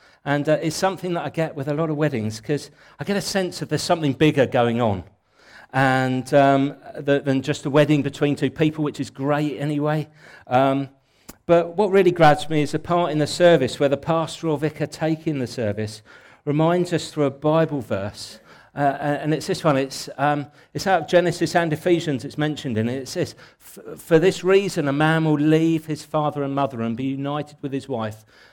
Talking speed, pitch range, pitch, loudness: 210 wpm, 135-160 Hz, 150 Hz, -21 LUFS